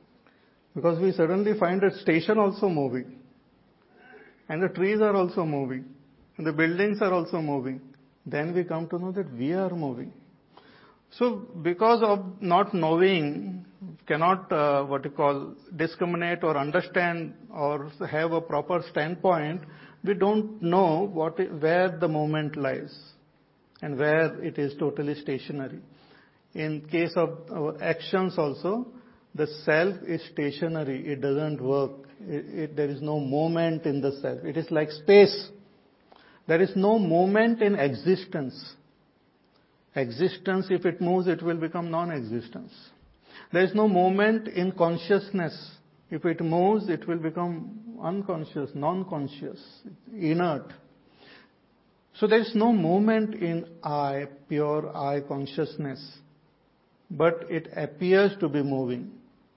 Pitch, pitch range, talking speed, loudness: 165 Hz, 150-190 Hz, 130 wpm, -26 LUFS